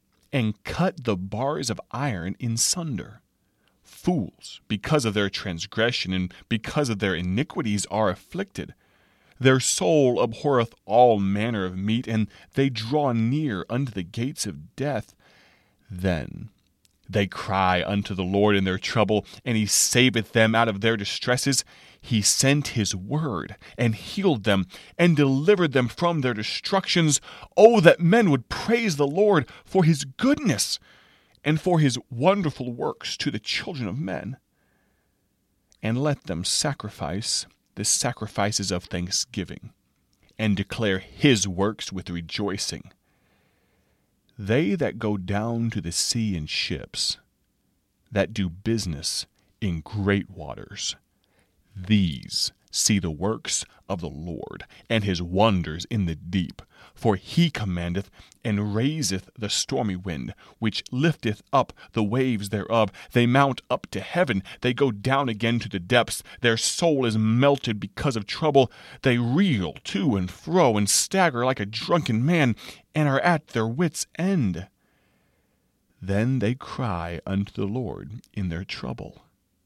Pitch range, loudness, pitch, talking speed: 95-135 Hz, -24 LUFS, 110 Hz, 140 wpm